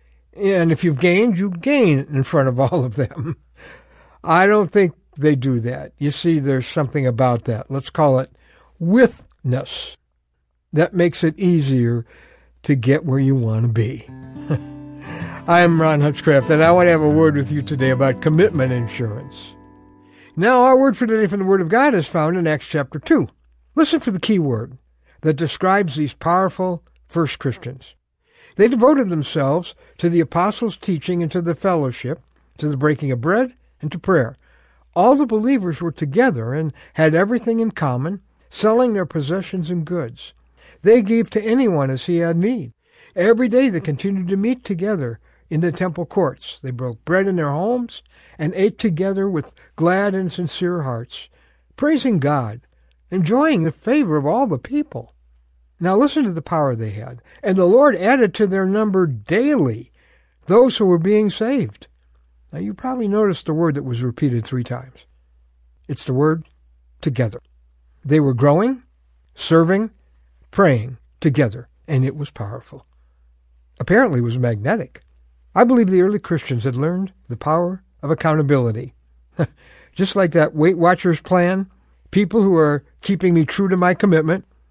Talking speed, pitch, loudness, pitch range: 165 wpm, 155 Hz, -18 LUFS, 125-190 Hz